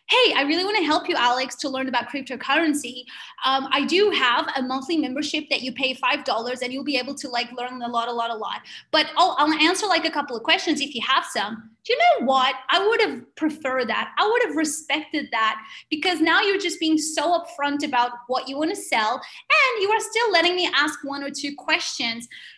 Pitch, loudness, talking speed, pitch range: 285 Hz, -22 LUFS, 230 wpm, 255-335 Hz